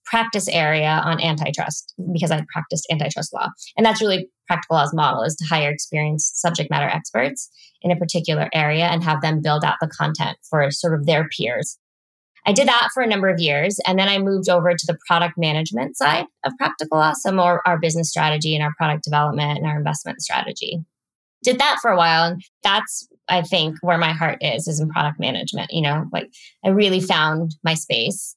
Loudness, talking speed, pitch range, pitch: -20 LUFS, 205 wpm, 155-180 Hz, 165 Hz